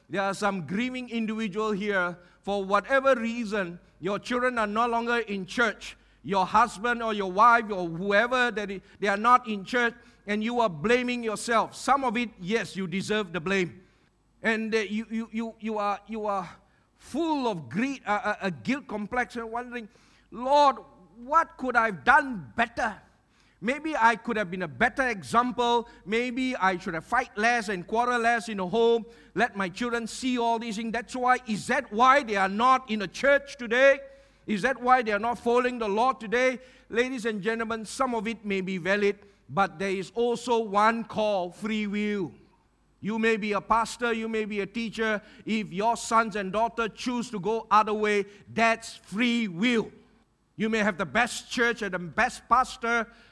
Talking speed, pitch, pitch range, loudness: 185 wpm, 225 Hz, 205-240 Hz, -26 LUFS